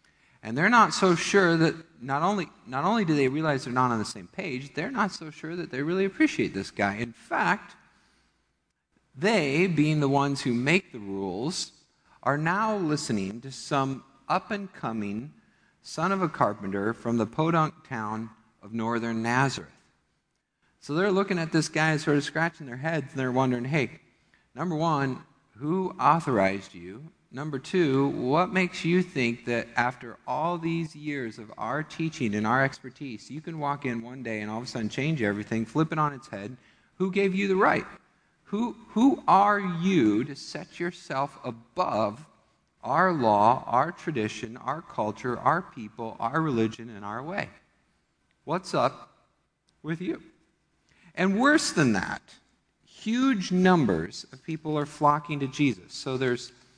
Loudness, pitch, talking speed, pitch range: -27 LUFS, 145 Hz, 165 wpm, 120-170 Hz